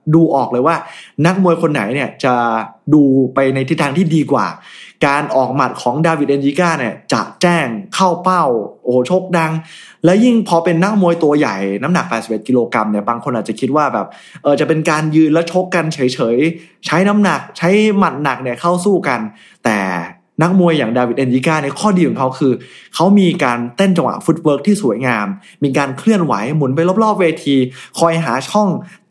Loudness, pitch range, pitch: -14 LUFS, 130-175 Hz, 155 Hz